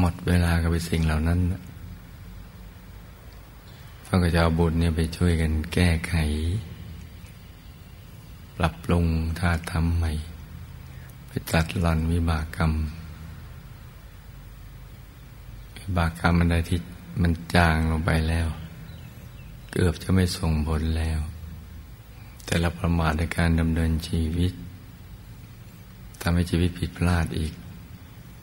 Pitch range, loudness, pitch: 80-90 Hz, -25 LUFS, 85 Hz